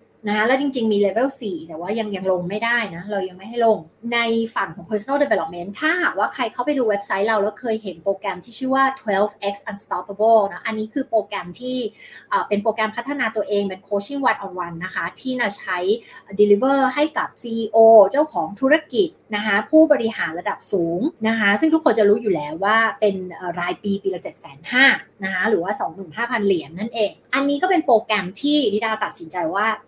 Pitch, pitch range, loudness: 215 Hz, 200-250 Hz, -20 LUFS